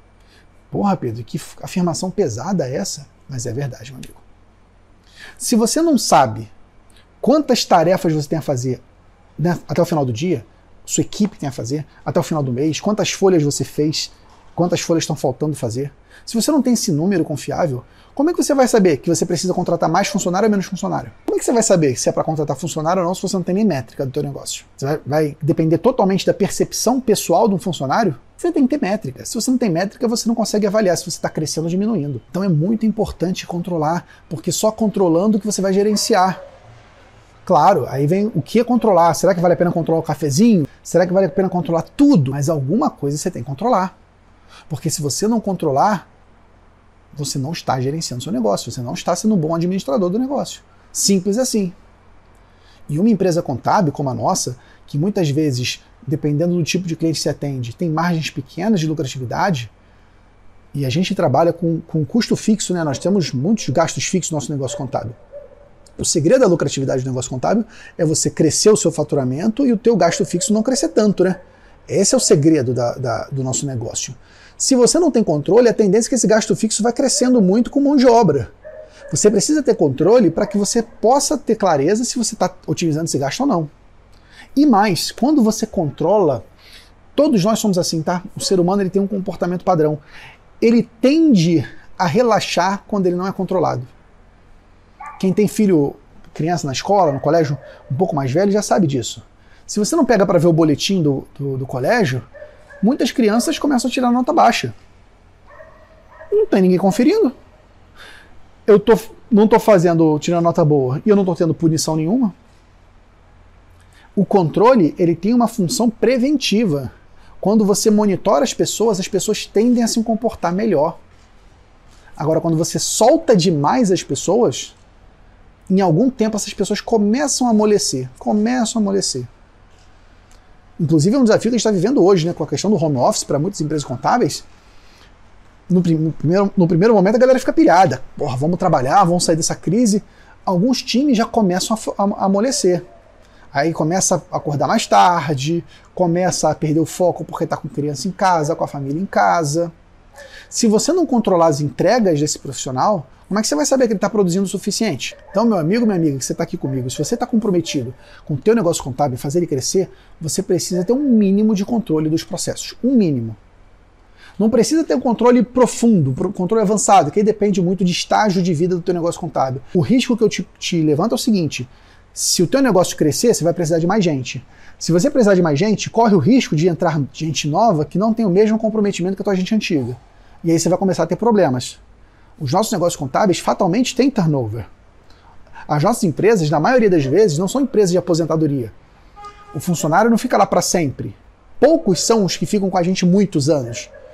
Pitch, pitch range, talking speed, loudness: 175 Hz, 140-210 Hz, 195 wpm, -17 LUFS